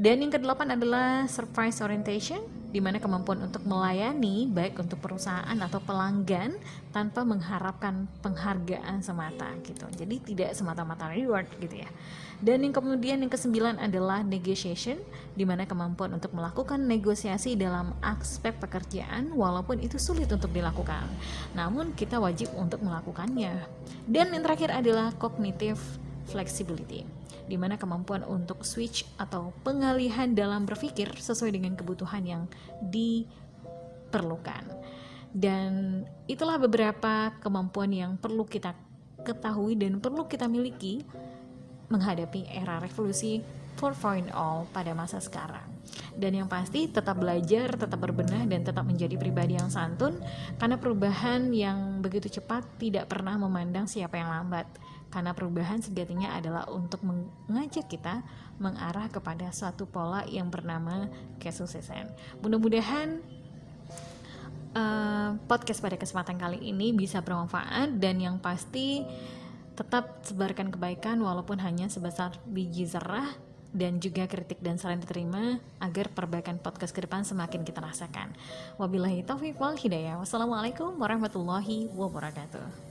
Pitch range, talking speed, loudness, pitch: 175-220 Hz, 125 wpm, -31 LUFS, 195 Hz